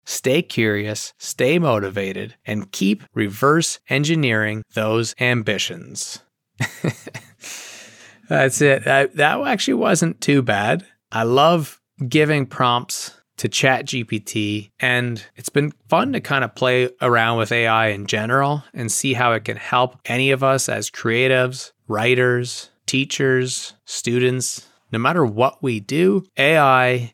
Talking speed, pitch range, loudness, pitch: 130 wpm, 110-135 Hz, -19 LUFS, 125 Hz